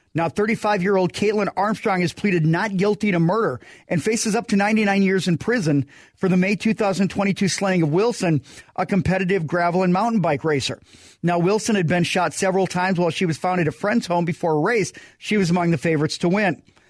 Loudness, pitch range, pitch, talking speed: -21 LUFS, 170-200 Hz, 185 Hz, 210 wpm